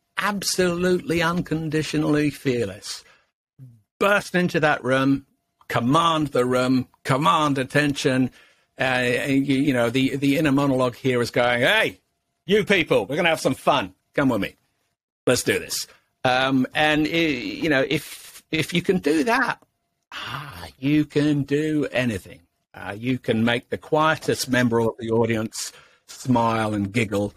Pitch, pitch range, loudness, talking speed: 135 Hz, 125-155 Hz, -22 LUFS, 150 wpm